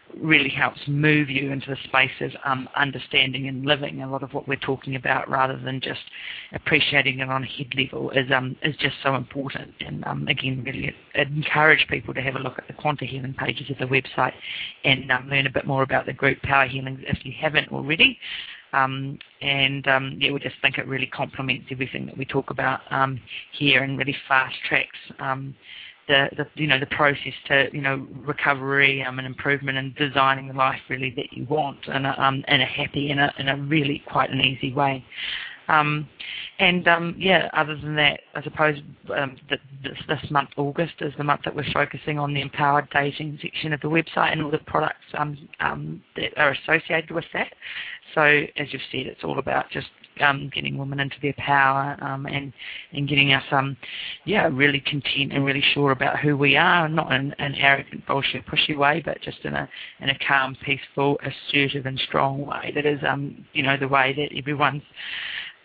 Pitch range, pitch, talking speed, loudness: 135-145 Hz, 140 Hz, 200 wpm, -22 LUFS